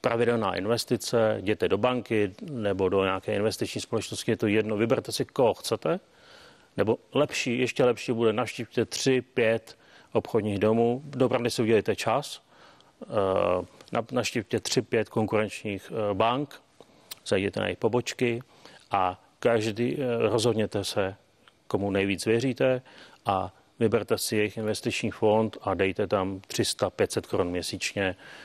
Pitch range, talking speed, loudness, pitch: 105-120 Hz, 125 wpm, -27 LUFS, 115 Hz